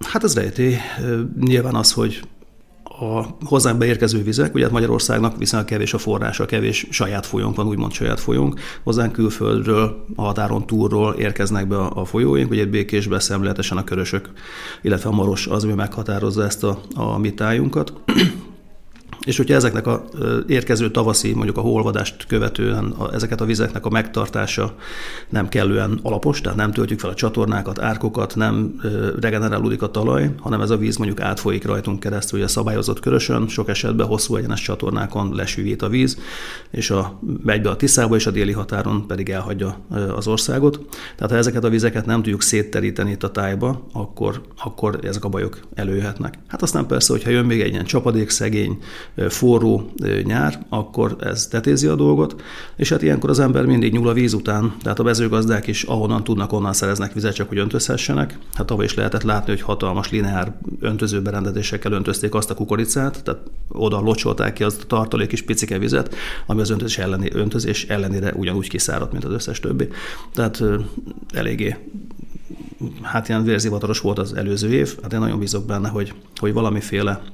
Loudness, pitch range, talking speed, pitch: -20 LUFS, 100-115 Hz, 170 wpm, 105 Hz